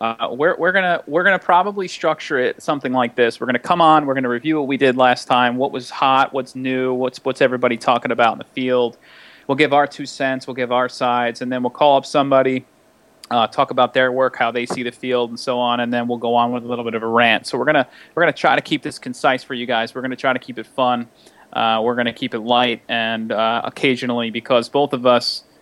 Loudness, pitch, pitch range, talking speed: -18 LUFS, 125 Hz, 120-135 Hz, 260 wpm